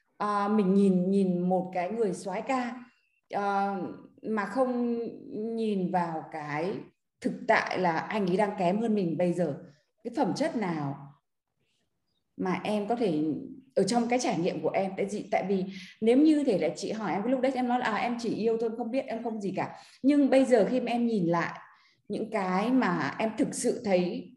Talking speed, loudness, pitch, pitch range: 205 wpm, -29 LUFS, 215 Hz, 185-240 Hz